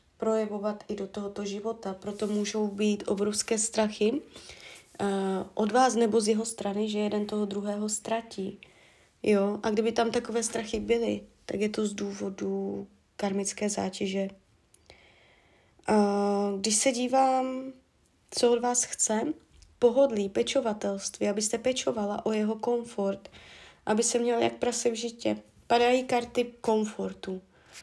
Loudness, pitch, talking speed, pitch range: -29 LUFS, 215 Hz, 130 wpm, 200-235 Hz